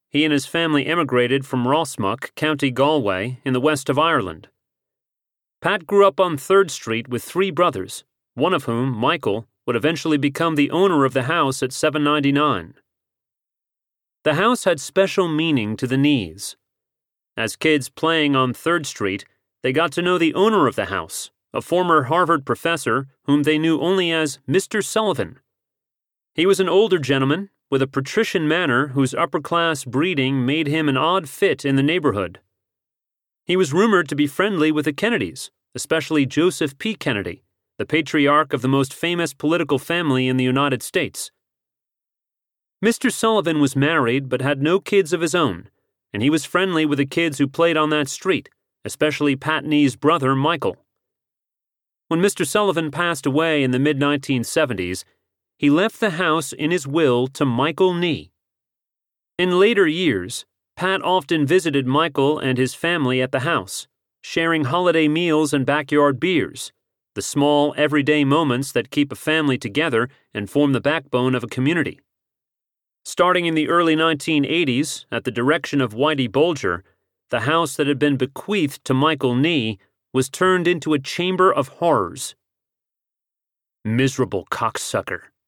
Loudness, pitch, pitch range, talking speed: -20 LUFS, 150 Hz, 135-170 Hz, 160 wpm